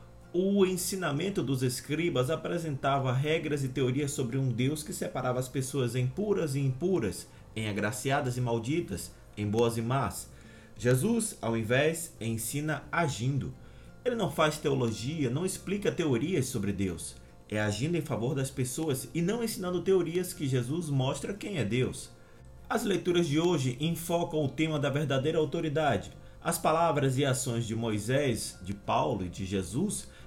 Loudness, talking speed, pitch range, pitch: -30 LUFS, 155 wpm, 120-165 Hz, 140 Hz